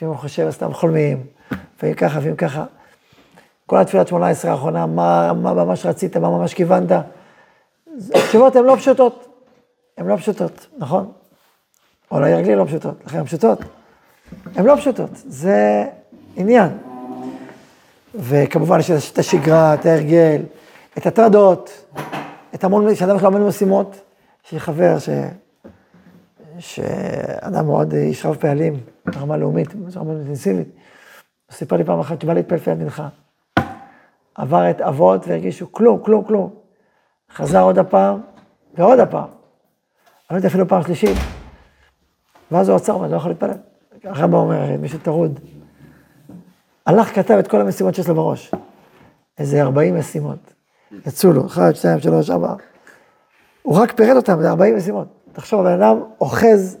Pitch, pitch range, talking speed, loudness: 170 Hz, 135-200 Hz, 135 wpm, -16 LUFS